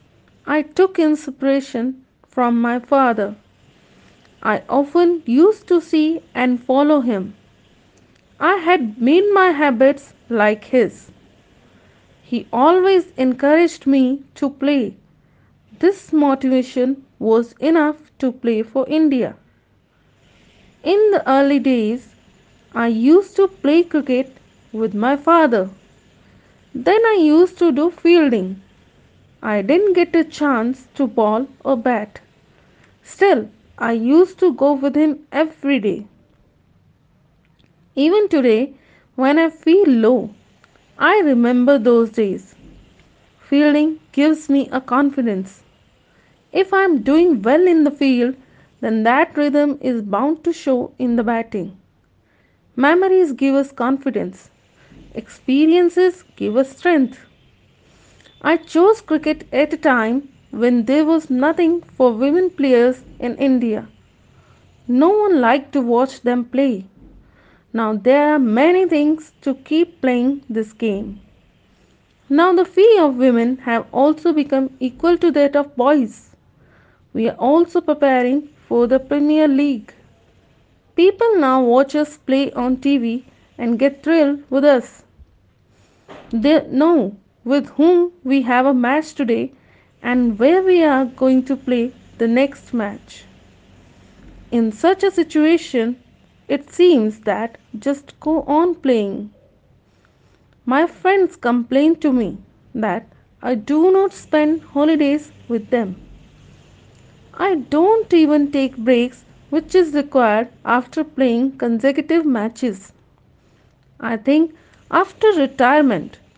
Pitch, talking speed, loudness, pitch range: 275 Hz, 120 wpm, -16 LUFS, 240-315 Hz